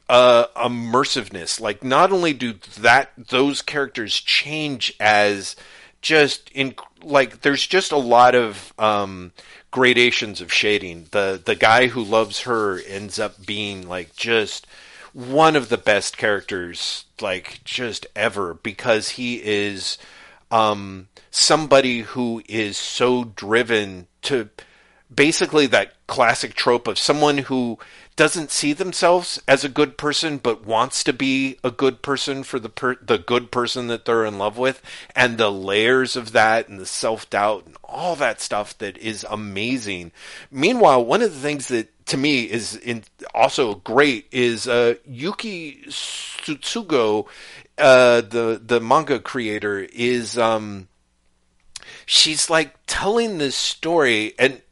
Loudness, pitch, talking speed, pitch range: -19 LUFS, 120 Hz, 140 wpm, 105-140 Hz